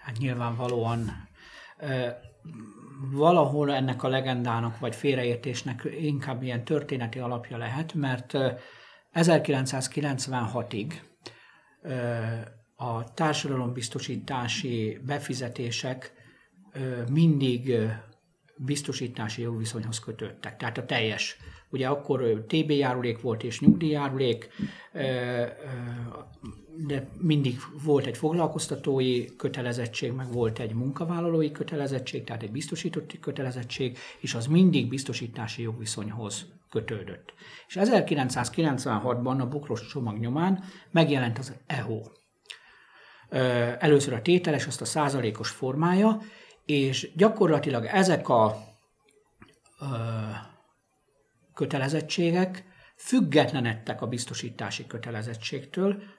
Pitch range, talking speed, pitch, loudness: 120-150 Hz, 85 wpm, 130 Hz, -28 LUFS